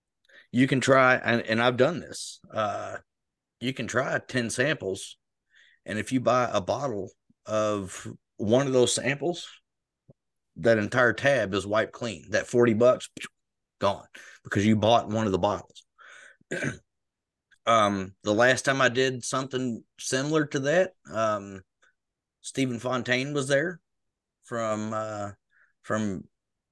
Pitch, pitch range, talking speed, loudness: 120 Hz, 110-130 Hz, 135 wpm, -26 LUFS